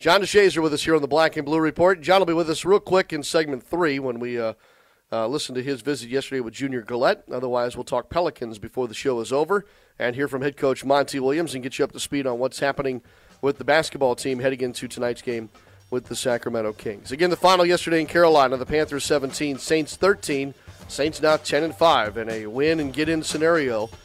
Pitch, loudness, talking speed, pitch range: 140 Hz, -23 LUFS, 230 wpm, 125-160 Hz